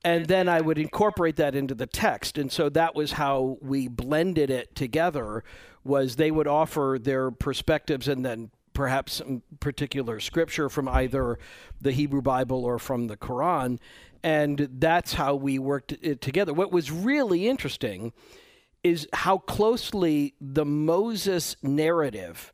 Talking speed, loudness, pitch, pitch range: 150 wpm, -26 LUFS, 145 Hz, 135-165 Hz